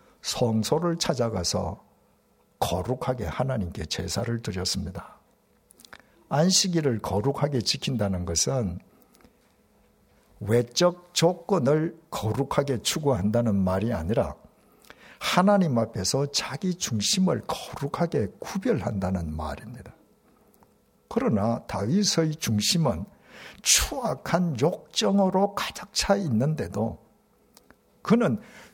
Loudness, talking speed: -26 LUFS, 220 characters per minute